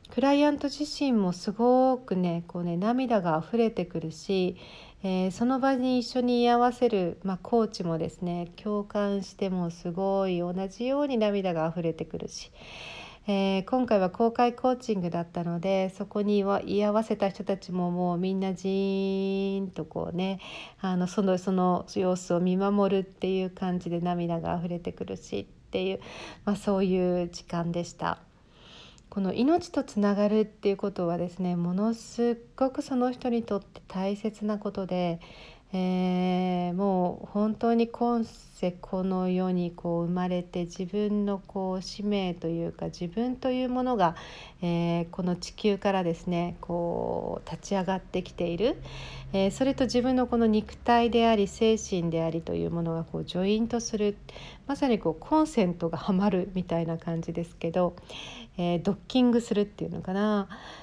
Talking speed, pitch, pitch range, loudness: 320 characters per minute, 195 Hz, 175-220 Hz, -28 LUFS